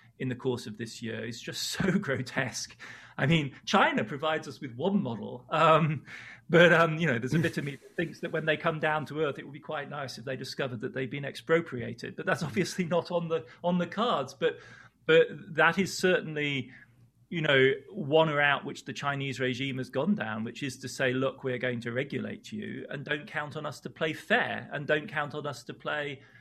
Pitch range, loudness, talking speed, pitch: 130-165 Hz, -29 LUFS, 225 wpm, 145 Hz